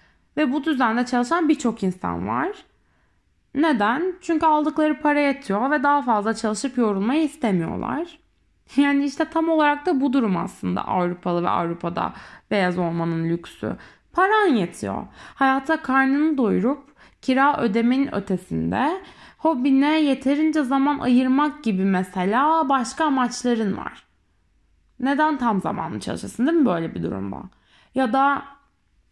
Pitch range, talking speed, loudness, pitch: 215-300 Hz, 125 wpm, -22 LUFS, 270 Hz